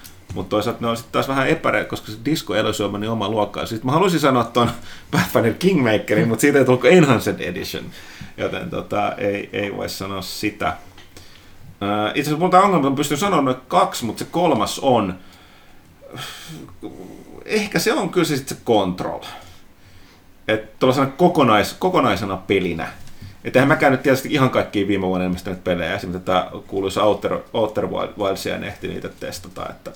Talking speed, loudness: 170 wpm, -19 LUFS